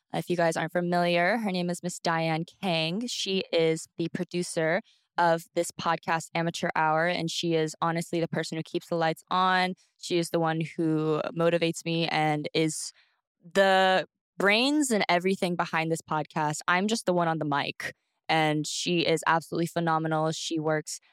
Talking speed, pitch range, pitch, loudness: 175 wpm, 160-175 Hz, 170 Hz, -27 LUFS